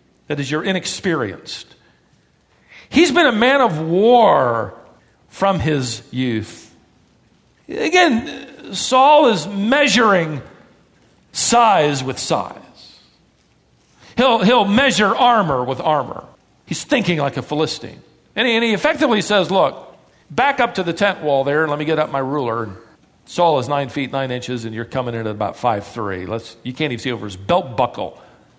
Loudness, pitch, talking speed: -17 LUFS, 155 Hz, 155 wpm